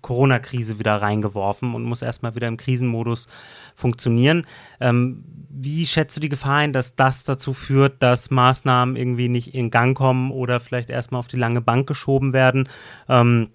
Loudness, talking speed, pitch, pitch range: -20 LUFS, 170 wpm, 125 Hz, 120-135 Hz